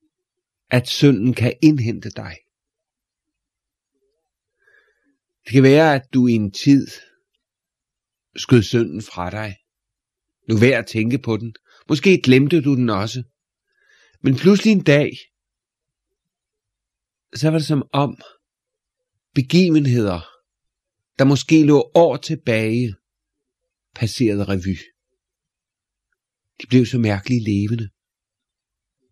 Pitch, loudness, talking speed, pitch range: 135 Hz, -17 LUFS, 105 wpm, 115-170 Hz